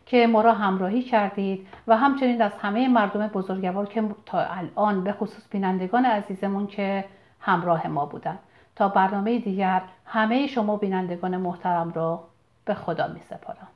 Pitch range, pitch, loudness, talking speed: 185-220 Hz, 200 Hz, -24 LUFS, 150 wpm